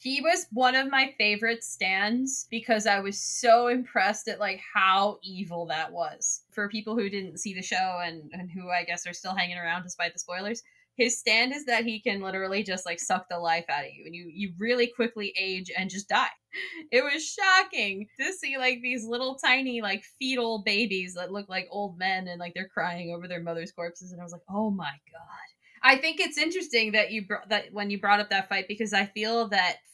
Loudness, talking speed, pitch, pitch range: -27 LUFS, 225 wpm, 205 Hz, 185-240 Hz